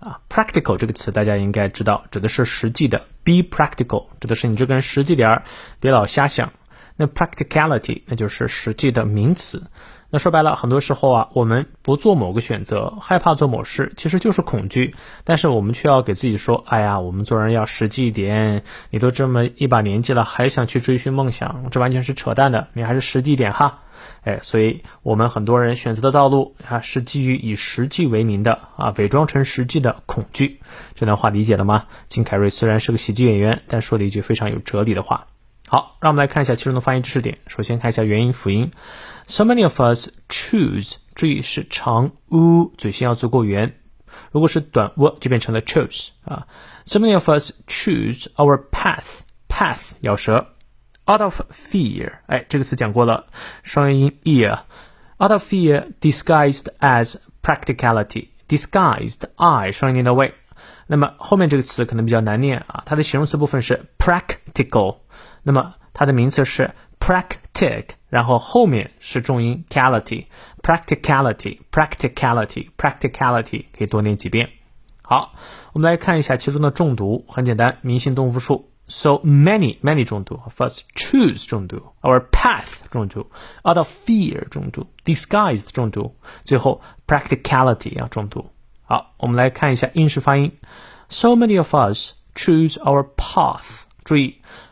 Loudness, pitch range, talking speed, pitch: -18 LUFS, 115-145 Hz, 390 characters per minute, 130 Hz